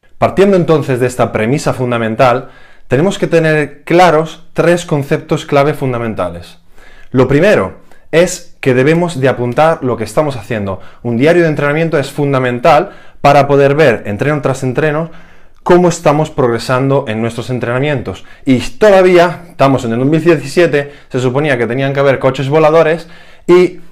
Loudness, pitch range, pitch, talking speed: -12 LUFS, 125-160 Hz, 145 Hz, 145 wpm